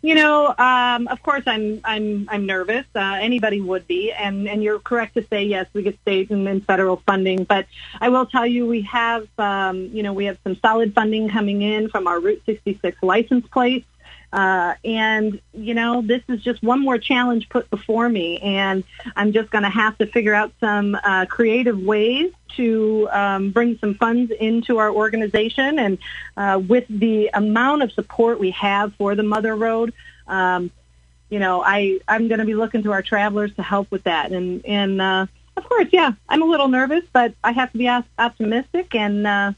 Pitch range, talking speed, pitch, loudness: 200-240 Hz, 200 wpm, 215 Hz, -19 LUFS